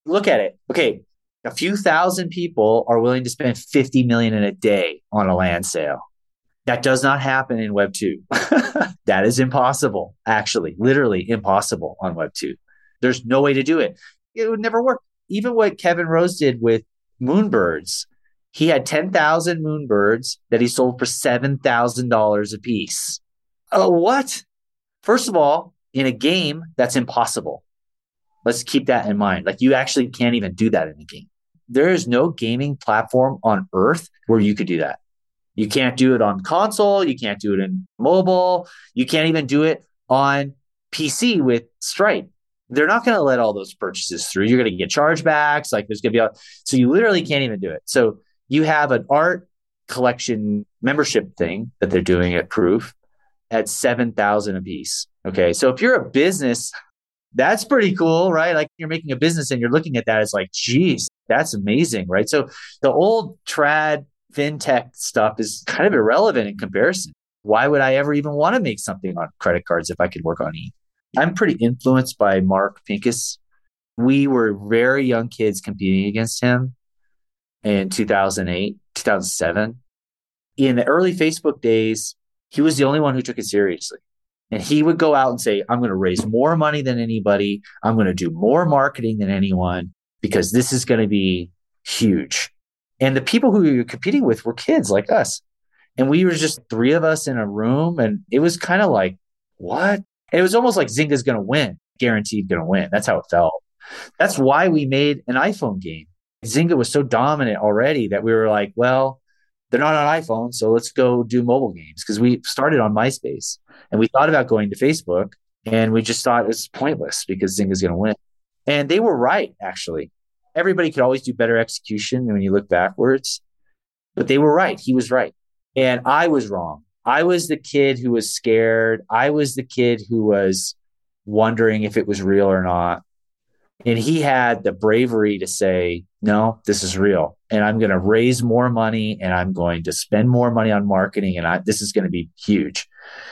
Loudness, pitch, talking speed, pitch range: -19 LUFS, 120 Hz, 195 wpm, 105-145 Hz